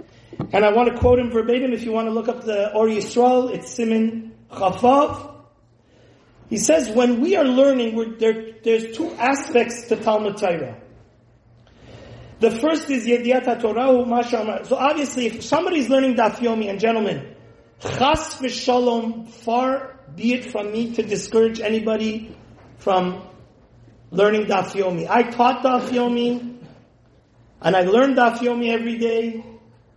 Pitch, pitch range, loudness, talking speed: 230 Hz, 205-245 Hz, -20 LUFS, 135 wpm